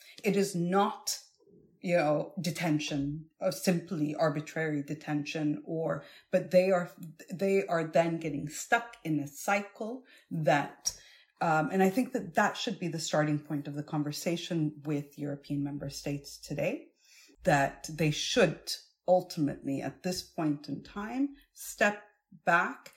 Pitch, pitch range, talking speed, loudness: 165 Hz, 150-195 Hz, 140 wpm, -31 LUFS